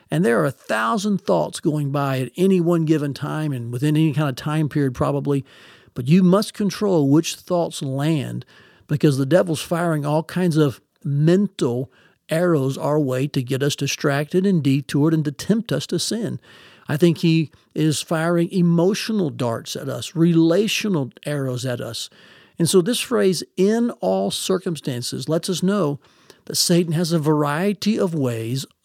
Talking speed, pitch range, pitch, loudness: 170 wpm, 140-180 Hz, 155 Hz, -20 LUFS